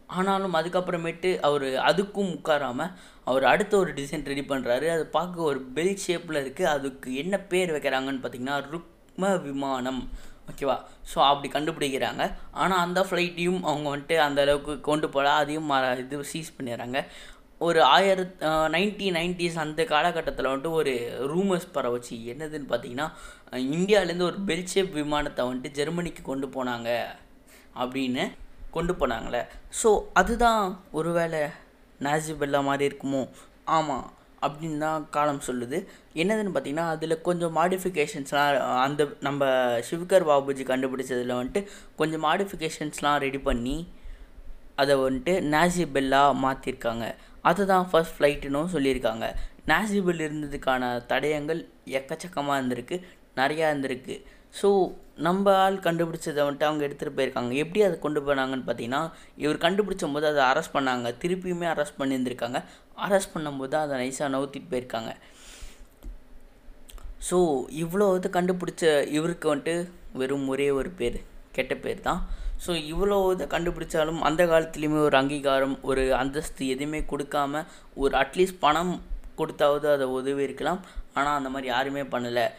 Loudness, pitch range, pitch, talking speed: -26 LUFS, 135-175 Hz, 150 Hz, 125 wpm